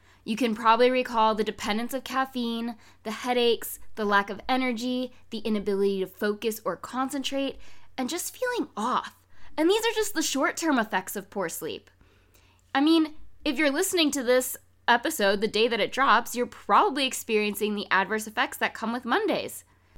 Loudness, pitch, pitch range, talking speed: -26 LUFS, 245 Hz, 220-275 Hz, 170 wpm